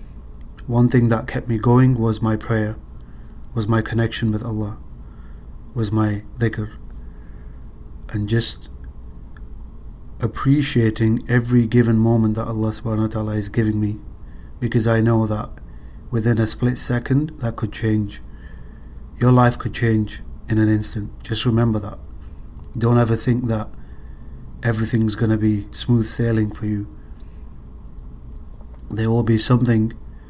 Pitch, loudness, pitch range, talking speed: 110 Hz, -19 LUFS, 70-115 Hz, 135 wpm